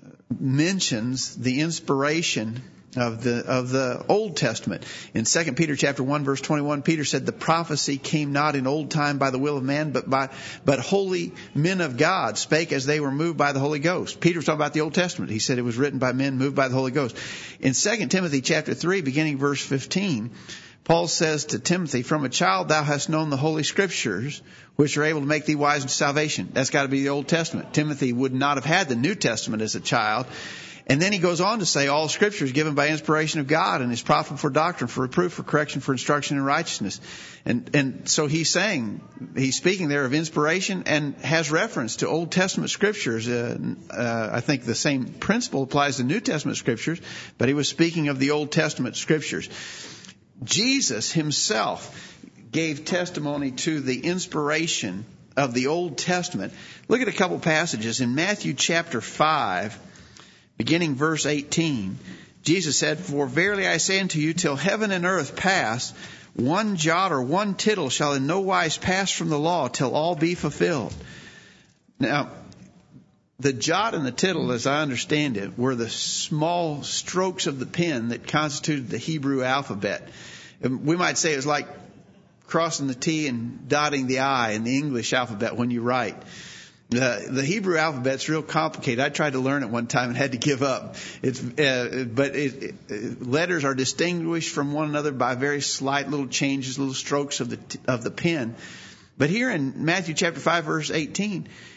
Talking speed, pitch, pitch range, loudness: 190 wpm, 150 Hz, 135-165 Hz, -24 LUFS